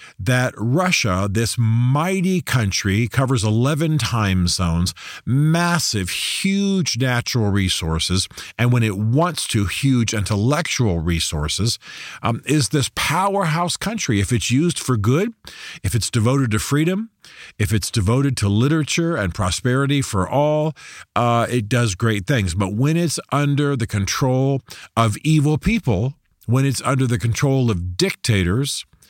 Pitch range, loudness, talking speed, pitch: 105-145 Hz, -19 LUFS, 135 wpm, 120 Hz